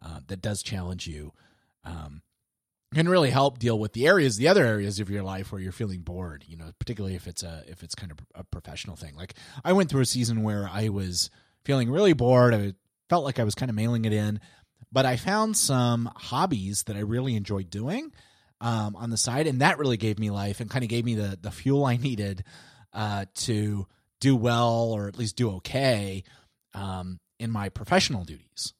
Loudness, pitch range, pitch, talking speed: -26 LUFS, 95-125 Hz, 105 Hz, 215 wpm